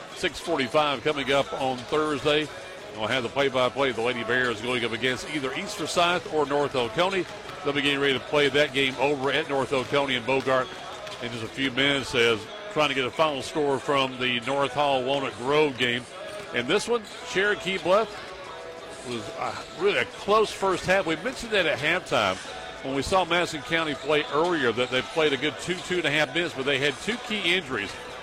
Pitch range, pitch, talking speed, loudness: 130-165 Hz, 145 Hz, 195 wpm, -25 LUFS